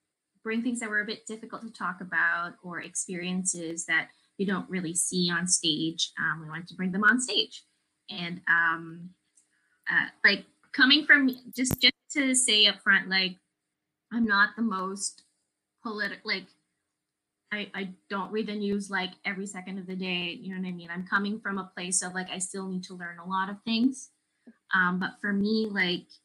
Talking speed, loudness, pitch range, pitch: 190 wpm, -27 LUFS, 180-215 Hz, 190 Hz